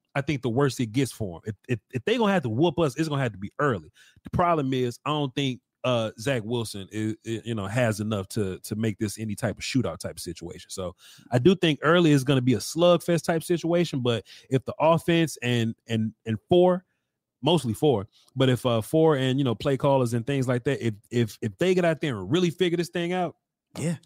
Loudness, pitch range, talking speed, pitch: -25 LUFS, 115-160 Hz, 245 wpm, 130 Hz